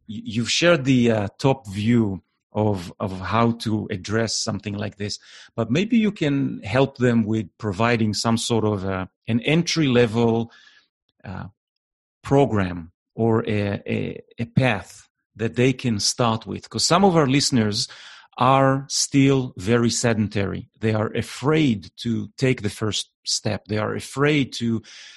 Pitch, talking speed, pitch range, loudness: 115 Hz, 150 wpm, 105-130 Hz, -22 LUFS